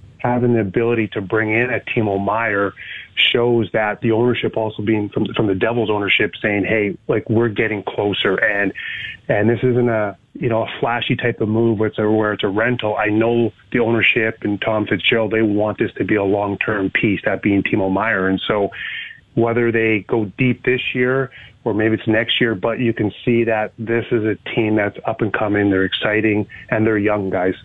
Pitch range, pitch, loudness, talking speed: 105-115 Hz, 110 Hz, -18 LUFS, 210 wpm